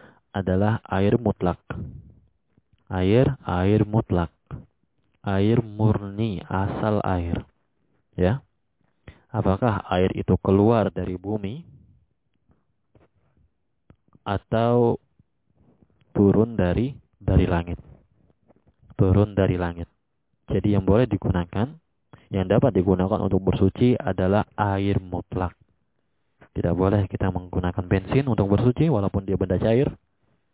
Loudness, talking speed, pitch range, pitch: -23 LUFS, 95 wpm, 95-110 Hz, 100 Hz